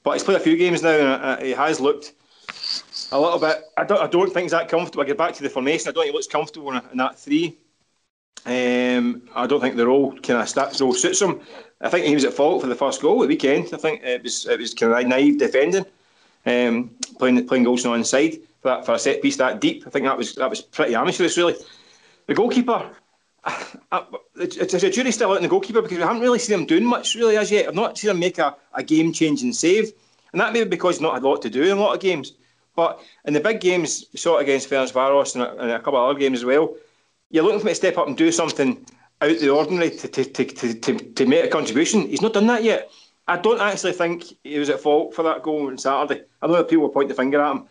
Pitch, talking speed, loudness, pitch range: 165 Hz, 265 wpm, -20 LUFS, 135-210 Hz